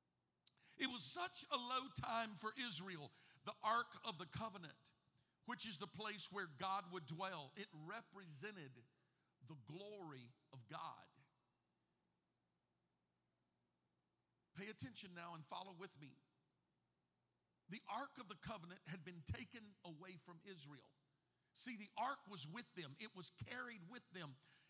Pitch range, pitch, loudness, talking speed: 145-210 Hz, 180 Hz, -50 LUFS, 135 wpm